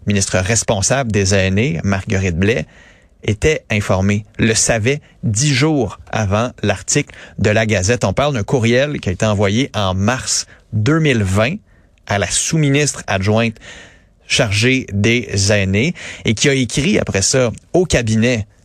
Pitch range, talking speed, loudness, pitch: 100-130 Hz, 140 wpm, -16 LUFS, 110 Hz